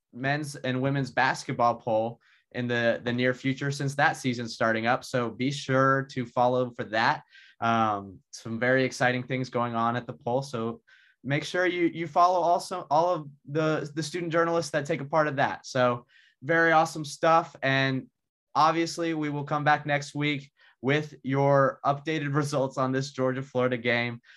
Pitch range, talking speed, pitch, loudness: 125-150 Hz, 175 wpm, 135 Hz, -27 LUFS